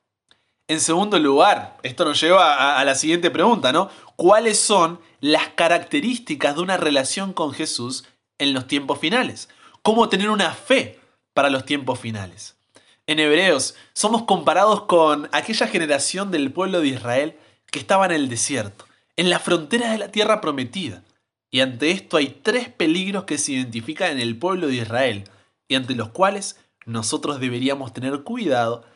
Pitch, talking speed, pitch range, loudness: 155 Hz, 160 wpm, 130-195 Hz, -20 LUFS